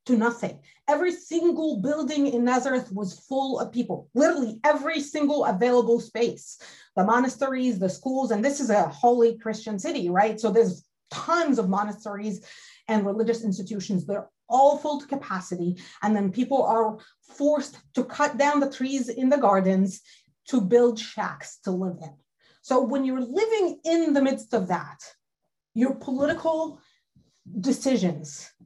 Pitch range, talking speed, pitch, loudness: 205-280 Hz, 150 wpm, 245 Hz, -25 LUFS